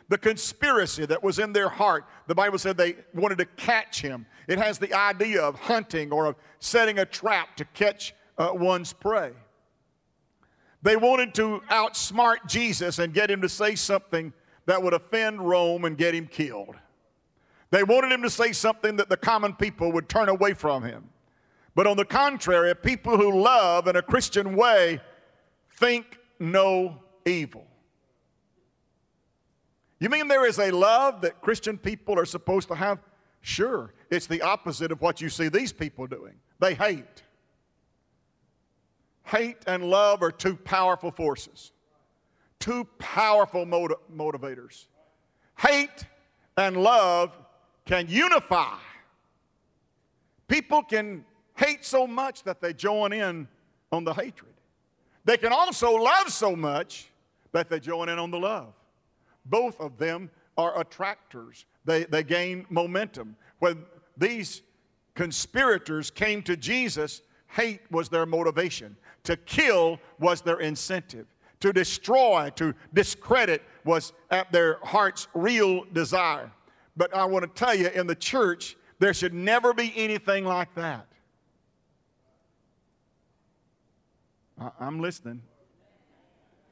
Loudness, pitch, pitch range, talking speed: -25 LUFS, 185 Hz, 165-210 Hz, 135 wpm